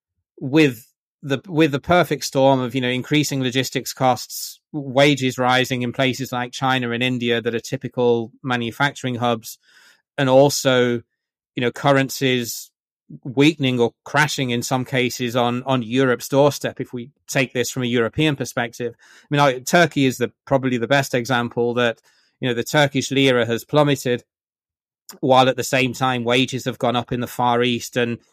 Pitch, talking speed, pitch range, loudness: 130 Hz, 165 wpm, 120-135 Hz, -20 LUFS